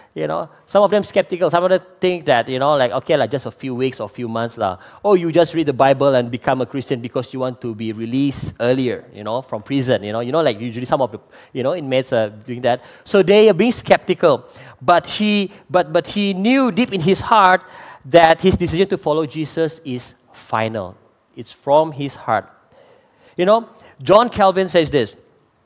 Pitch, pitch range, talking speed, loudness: 150 Hz, 125-185 Hz, 220 wpm, -17 LUFS